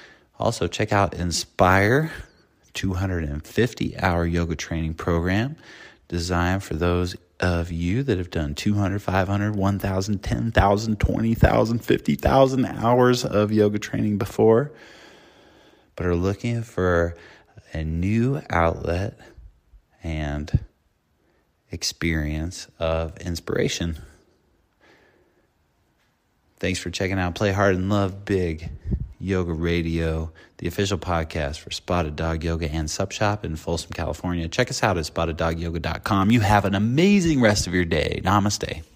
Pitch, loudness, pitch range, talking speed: 90 Hz, -23 LUFS, 85-105 Hz, 120 wpm